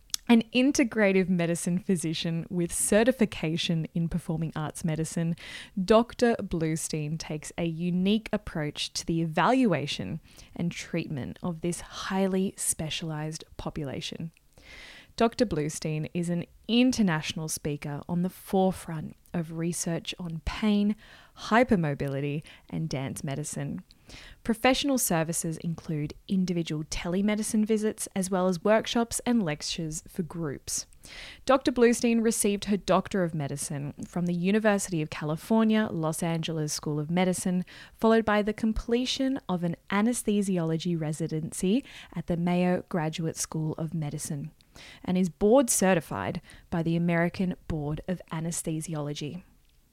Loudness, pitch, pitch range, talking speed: -28 LUFS, 175 Hz, 160-210 Hz, 120 wpm